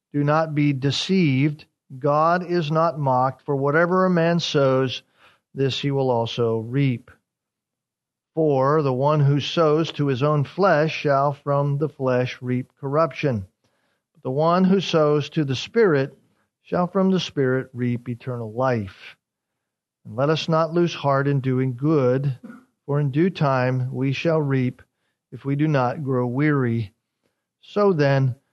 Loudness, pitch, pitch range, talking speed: -21 LUFS, 140 Hz, 130-160 Hz, 150 wpm